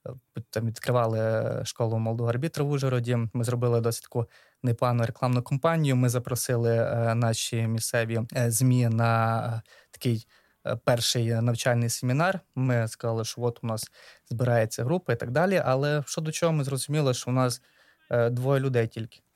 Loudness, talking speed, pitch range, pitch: -27 LUFS, 145 wpm, 115-130 Hz, 120 Hz